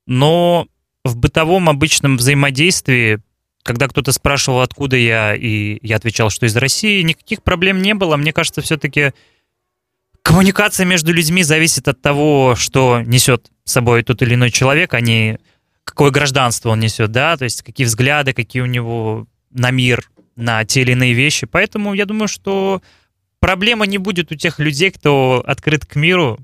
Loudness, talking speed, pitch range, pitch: -14 LUFS, 165 wpm, 120-160 Hz, 135 Hz